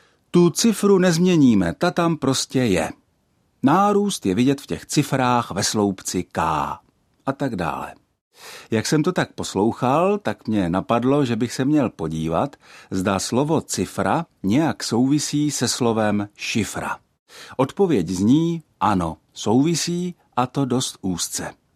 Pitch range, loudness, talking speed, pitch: 105-160 Hz, -21 LUFS, 130 wpm, 130 Hz